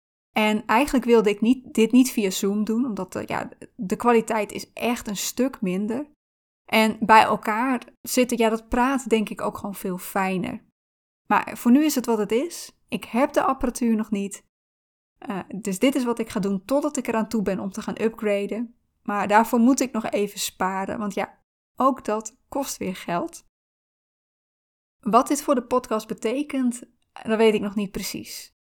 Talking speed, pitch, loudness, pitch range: 190 wpm, 220 Hz, -23 LUFS, 205-250 Hz